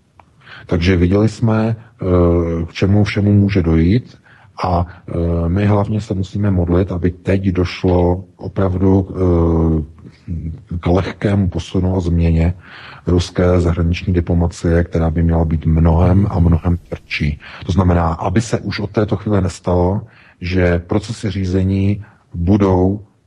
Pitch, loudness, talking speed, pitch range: 90 Hz, -16 LUFS, 120 wpm, 85-100 Hz